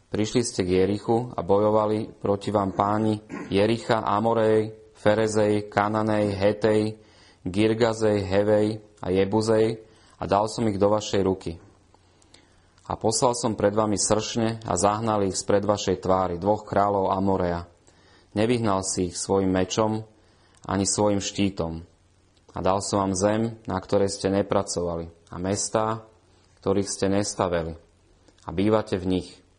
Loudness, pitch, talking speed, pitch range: -24 LUFS, 100 Hz, 135 wpm, 95-110 Hz